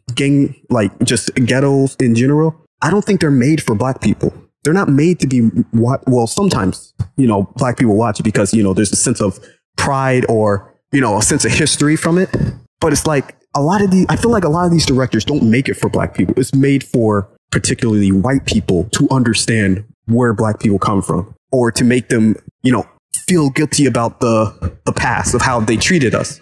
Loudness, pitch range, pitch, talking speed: -14 LUFS, 110-140 Hz, 125 Hz, 220 wpm